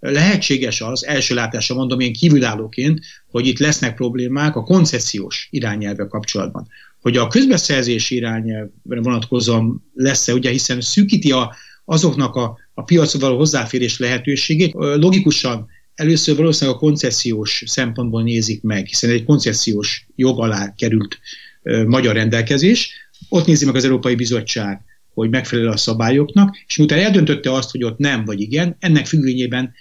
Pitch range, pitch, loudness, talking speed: 115-150 Hz, 130 Hz, -16 LUFS, 140 wpm